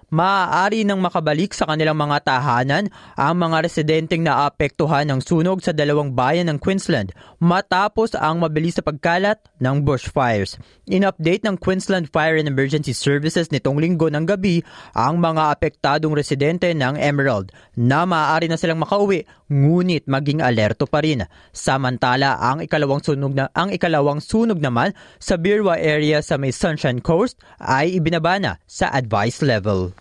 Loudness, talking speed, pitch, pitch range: -19 LUFS, 150 wpm, 155 Hz, 140-175 Hz